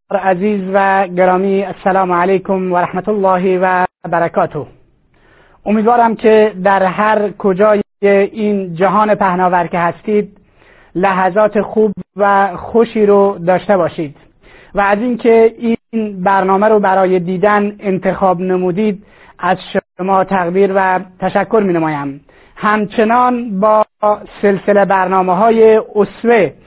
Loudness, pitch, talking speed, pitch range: -13 LUFS, 195 Hz, 110 wpm, 185-210 Hz